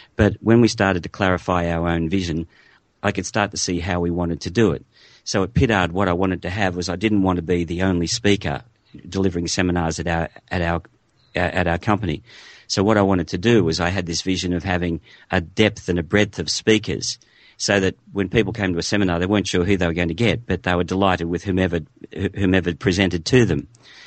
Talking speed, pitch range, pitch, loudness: 230 wpm, 85-100 Hz, 90 Hz, -21 LUFS